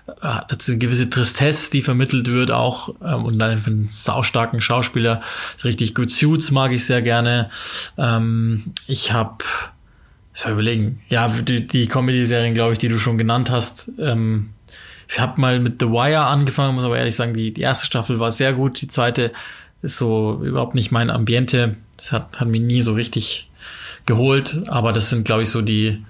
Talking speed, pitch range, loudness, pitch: 185 wpm, 115-125 Hz, -19 LUFS, 120 Hz